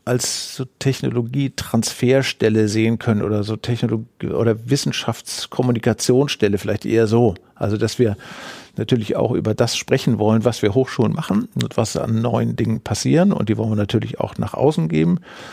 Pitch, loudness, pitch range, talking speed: 115 Hz, -19 LUFS, 110-125 Hz, 160 wpm